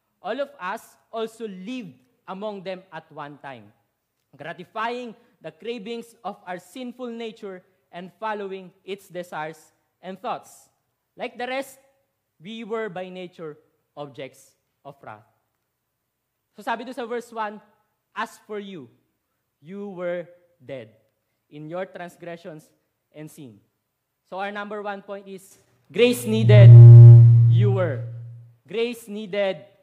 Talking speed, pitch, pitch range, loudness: 125 wpm, 180 Hz, 135-215 Hz, -15 LUFS